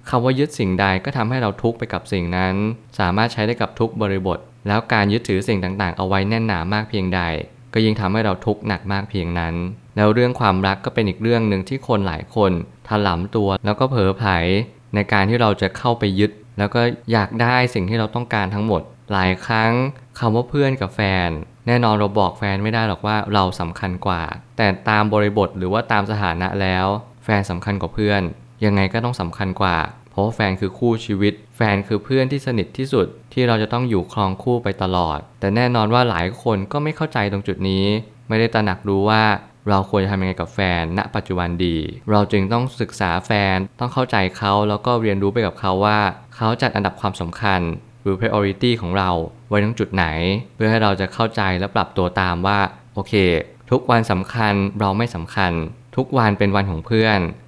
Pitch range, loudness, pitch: 95-115 Hz, -20 LUFS, 105 Hz